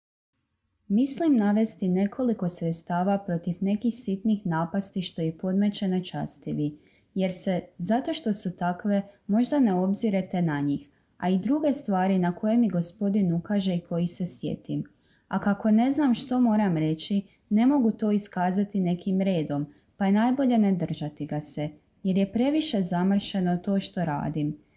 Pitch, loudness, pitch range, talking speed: 195 Hz, -26 LUFS, 175-215 Hz, 155 wpm